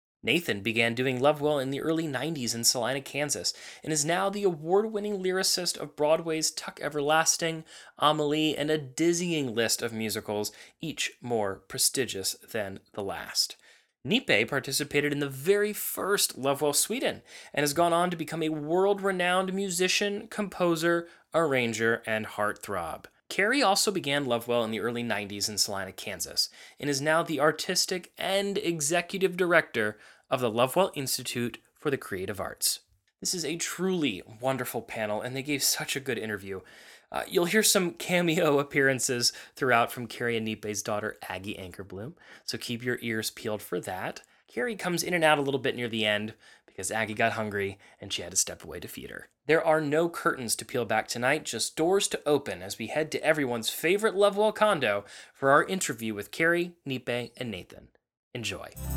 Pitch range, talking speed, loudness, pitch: 115-170 Hz, 175 wpm, -28 LUFS, 145 Hz